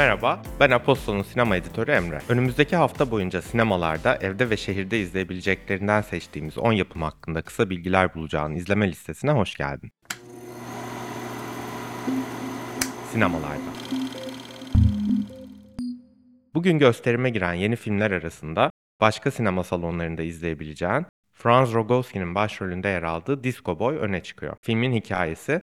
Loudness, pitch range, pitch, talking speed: -24 LUFS, 90-130 Hz, 105 Hz, 110 wpm